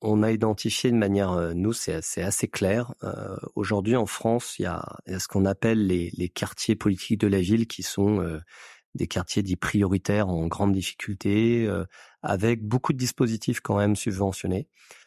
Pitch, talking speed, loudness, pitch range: 105 Hz, 185 wpm, -26 LUFS, 95-115 Hz